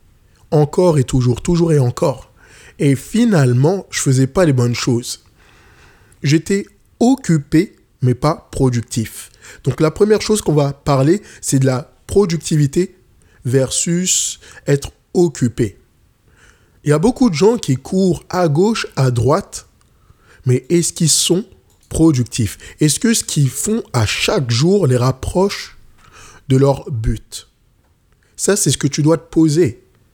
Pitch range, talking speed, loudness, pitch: 125-175 Hz, 145 wpm, -16 LUFS, 145 Hz